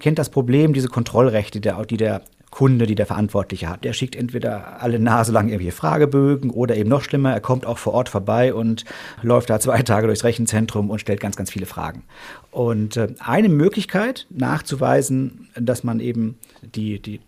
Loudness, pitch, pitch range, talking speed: -20 LUFS, 120 Hz, 110-130 Hz, 180 wpm